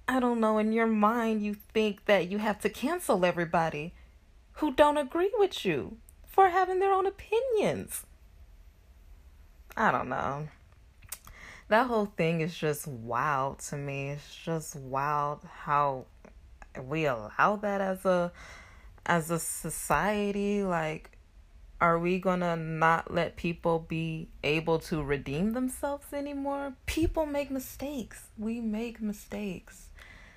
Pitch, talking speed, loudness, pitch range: 175 Hz, 130 wpm, -30 LUFS, 145-225 Hz